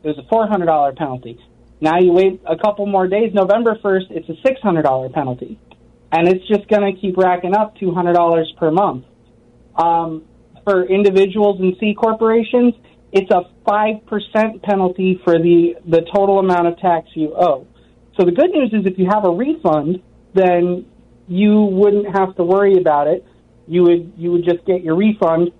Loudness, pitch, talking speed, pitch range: -16 LUFS, 185 Hz, 190 wpm, 165-205 Hz